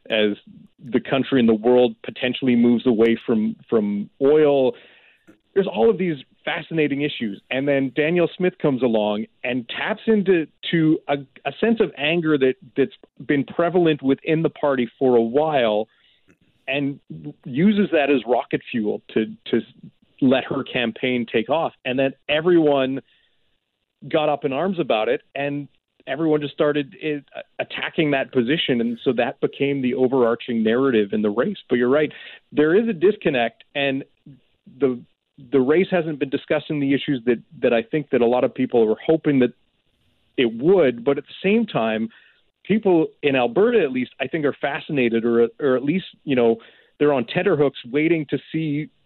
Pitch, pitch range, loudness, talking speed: 140 Hz, 125-160 Hz, -21 LUFS, 170 wpm